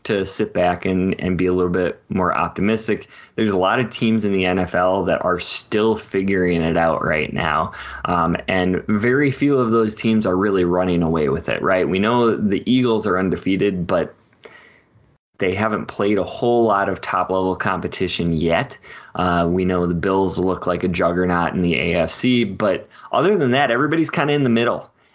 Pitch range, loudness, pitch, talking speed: 90-110 Hz, -19 LUFS, 95 Hz, 195 wpm